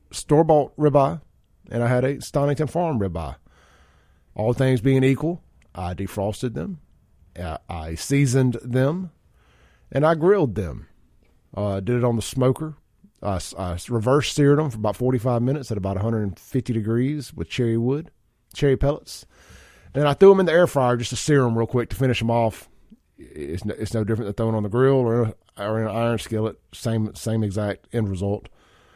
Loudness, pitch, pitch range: -22 LUFS, 115 Hz, 100-135 Hz